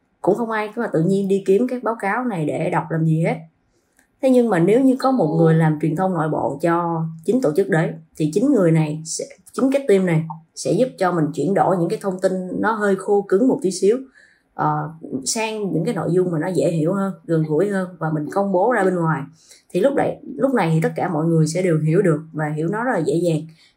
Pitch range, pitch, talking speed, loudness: 160-195 Hz, 175 Hz, 265 wpm, -20 LUFS